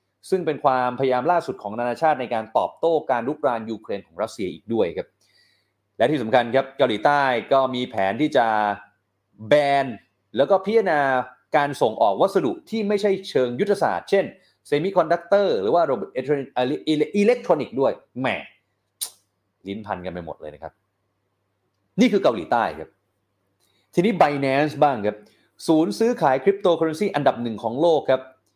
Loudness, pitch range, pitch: -22 LUFS, 105-160 Hz, 130 Hz